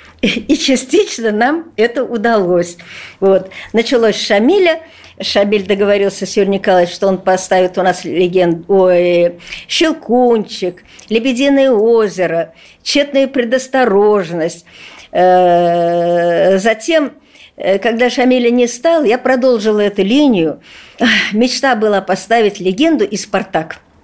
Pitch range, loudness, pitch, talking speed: 185-250 Hz, -13 LUFS, 210 Hz, 100 wpm